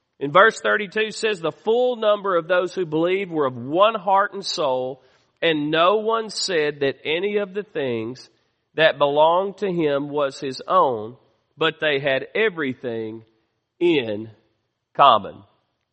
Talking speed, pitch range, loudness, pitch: 145 wpm, 130-200 Hz, -21 LUFS, 155 Hz